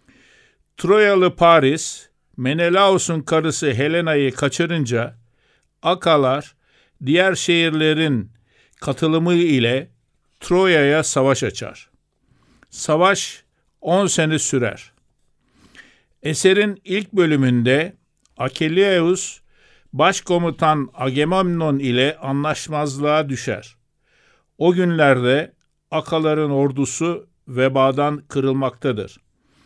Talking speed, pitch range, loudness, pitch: 65 wpm, 135-170 Hz, -18 LUFS, 150 Hz